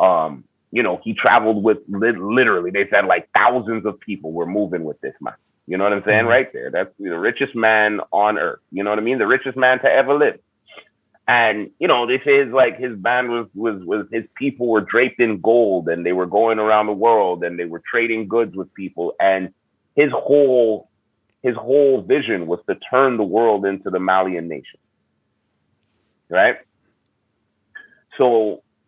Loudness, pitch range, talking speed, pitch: -18 LUFS, 100-125 Hz, 185 wpm, 110 Hz